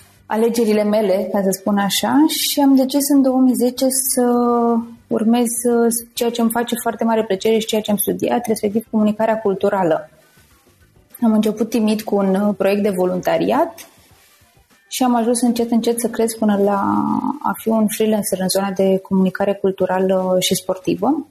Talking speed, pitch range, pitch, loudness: 160 wpm, 200-235 Hz, 220 Hz, -17 LUFS